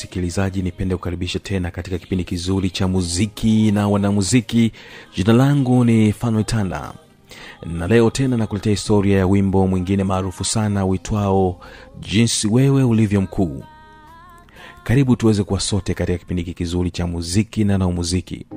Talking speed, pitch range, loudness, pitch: 135 wpm, 90-110 Hz, -19 LUFS, 100 Hz